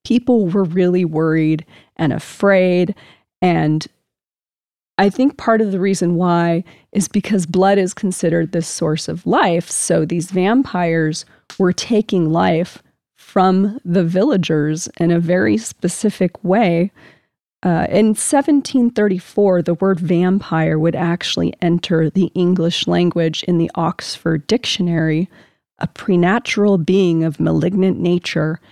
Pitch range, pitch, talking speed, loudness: 165-195 Hz, 180 Hz, 125 wpm, -17 LUFS